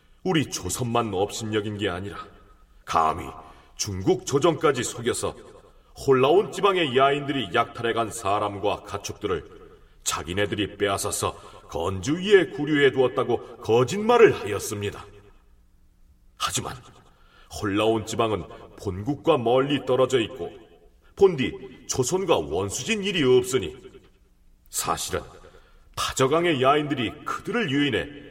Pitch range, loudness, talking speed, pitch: 100-145 Hz, -24 LUFS, 260 characters per minute, 130 Hz